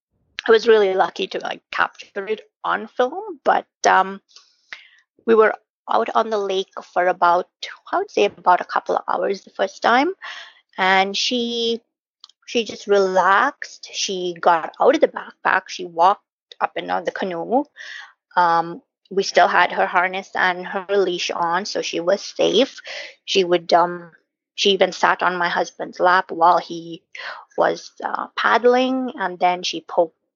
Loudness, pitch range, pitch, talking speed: -19 LUFS, 180-245 Hz, 195 Hz, 160 wpm